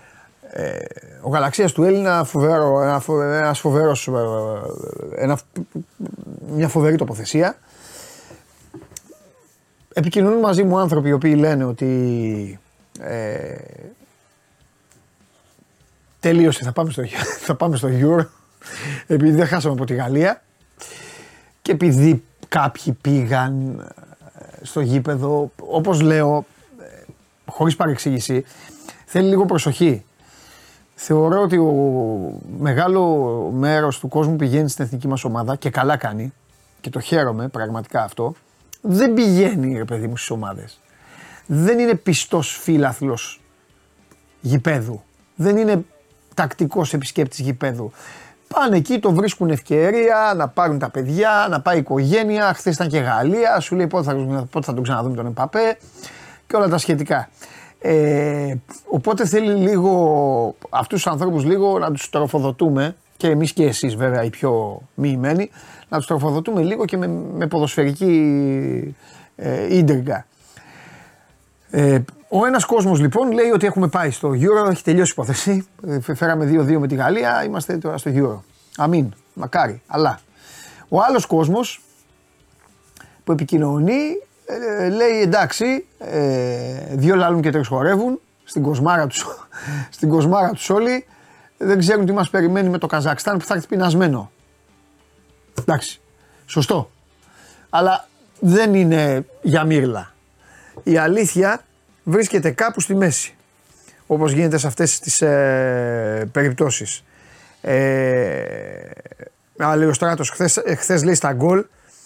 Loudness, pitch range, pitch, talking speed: -18 LUFS, 135-180 Hz, 155 Hz, 125 wpm